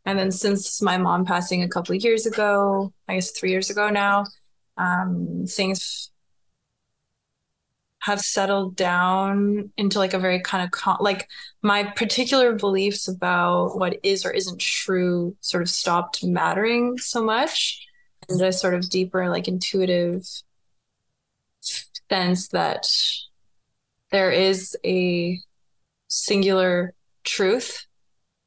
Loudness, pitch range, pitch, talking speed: -22 LUFS, 180-200 Hz, 185 Hz, 125 wpm